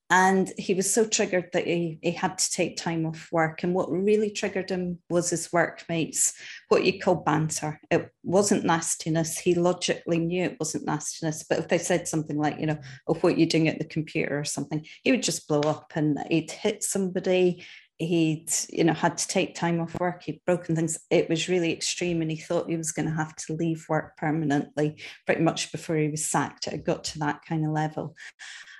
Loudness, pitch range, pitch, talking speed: -26 LUFS, 155-180 Hz, 165 Hz, 215 wpm